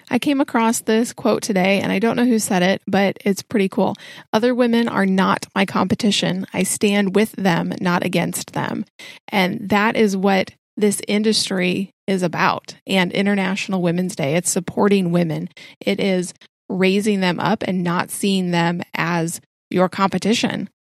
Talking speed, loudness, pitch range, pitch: 165 wpm, -19 LUFS, 185-215 Hz, 195 Hz